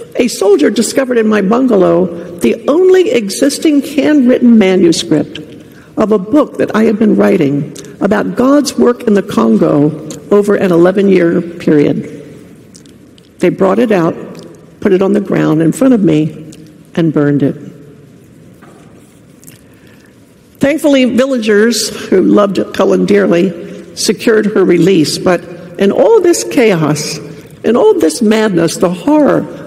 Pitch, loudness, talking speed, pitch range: 195 Hz, -10 LUFS, 135 wpm, 160-235 Hz